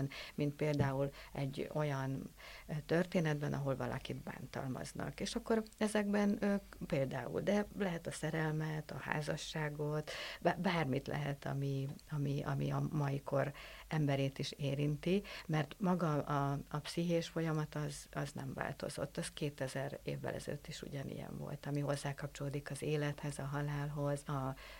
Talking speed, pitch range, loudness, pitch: 130 wpm, 140-165 Hz, -39 LUFS, 150 Hz